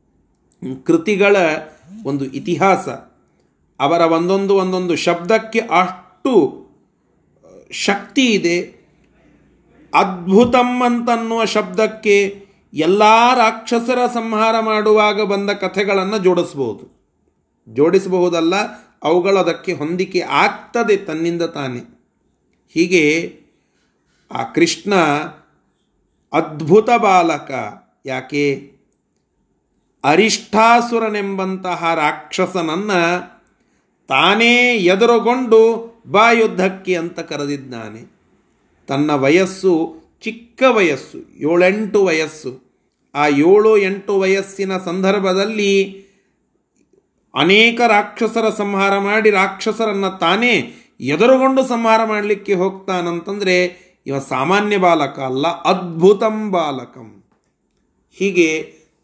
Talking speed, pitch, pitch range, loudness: 70 wpm, 190 Hz, 170-215 Hz, -15 LUFS